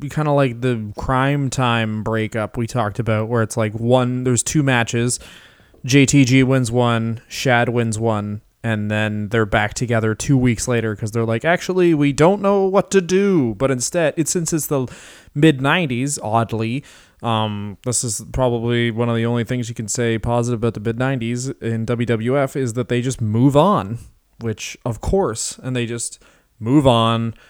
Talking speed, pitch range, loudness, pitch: 180 wpm, 115-135 Hz, -19 LUFS, 120 Hz